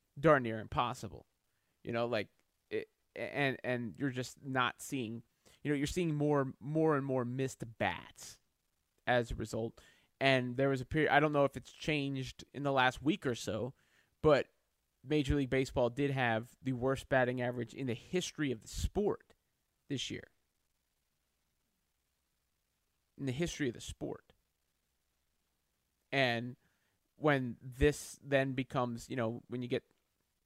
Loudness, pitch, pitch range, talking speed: -35 LUFS, 130 Hz, 115-140 Hz, 150 wpm